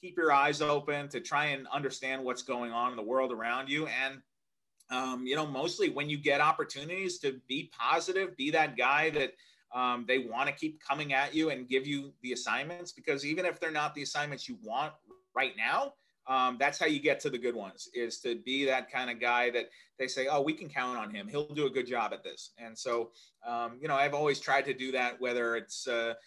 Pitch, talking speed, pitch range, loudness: 140 Hz, 230 wpm, 125-155 Hz, -32 LUFS